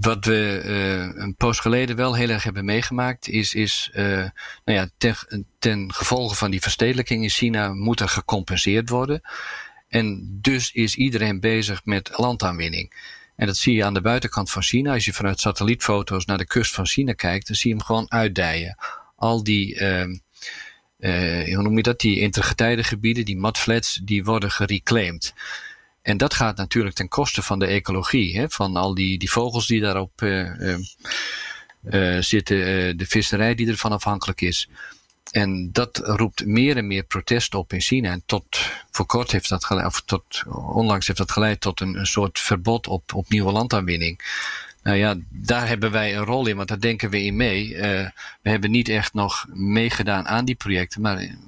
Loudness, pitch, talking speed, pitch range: -22 LUFS, 105 Hz, 185 wpm, 95-115 Hz